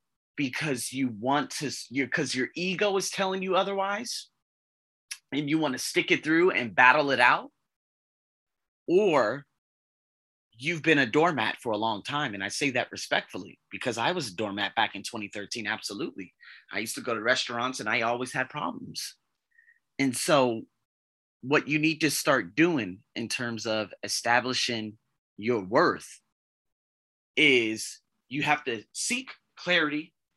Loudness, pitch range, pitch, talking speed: -27 LUFS, 110-155 Hz, 130 Hz, 150 wpm